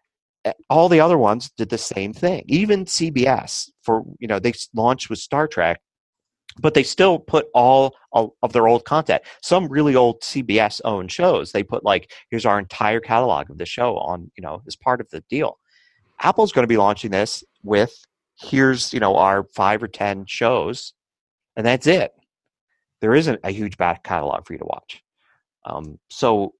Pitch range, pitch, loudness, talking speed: 105-155 Hz, 120 Hz, -19 LUFS, 185 wpm